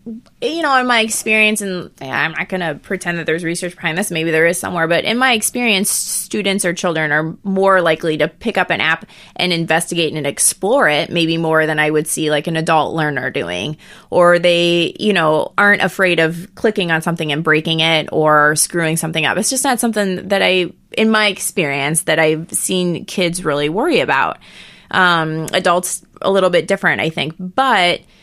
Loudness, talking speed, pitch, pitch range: -15 LUFS, 200 wpm, 170 Hz, 160-195 Hz